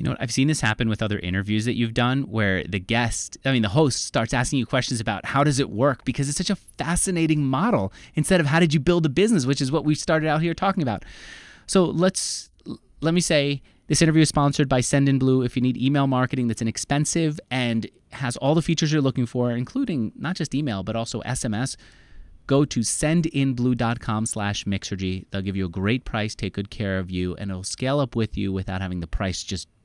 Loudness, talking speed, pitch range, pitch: -23 LUFS, 225 wpm, 110-150 Hz, 130 Hz